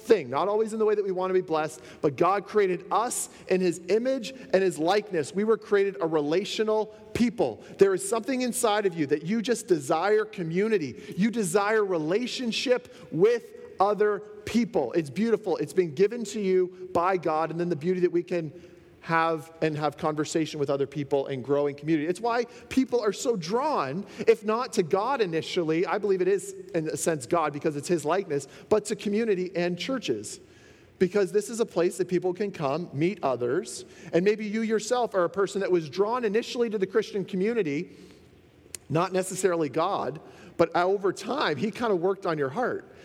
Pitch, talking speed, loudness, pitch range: 190 Hz, 190 wpm, -27 LUFS, 170-215 Hz